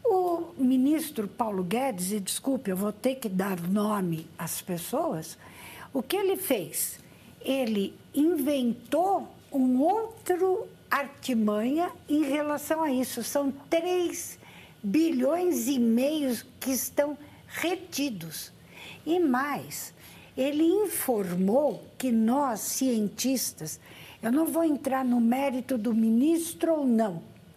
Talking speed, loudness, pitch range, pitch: 115 wpm, -28 LUFS, 225-315 Hz, 265 Hz